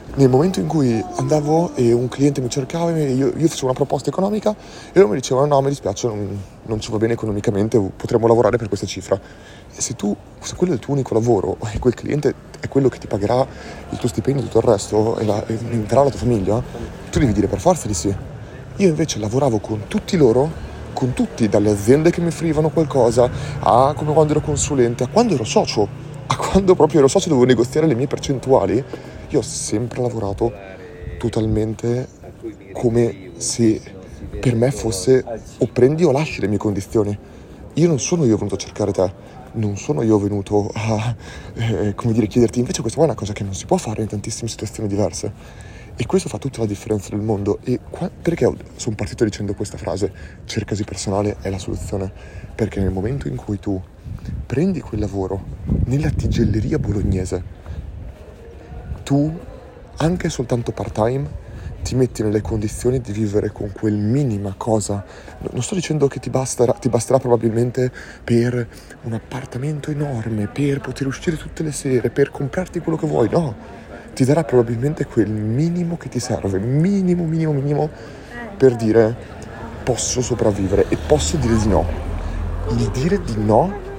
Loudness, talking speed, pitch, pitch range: -19 LUFS, 180 wpm, 115 Hz, 105-140 Hz